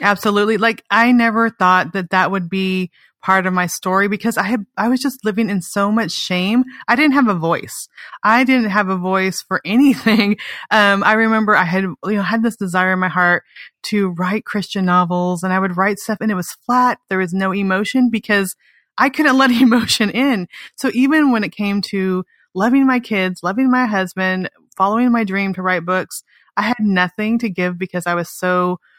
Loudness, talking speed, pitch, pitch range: -16 LUFS, 205 wpm, 200 Hz, 185-230 Hz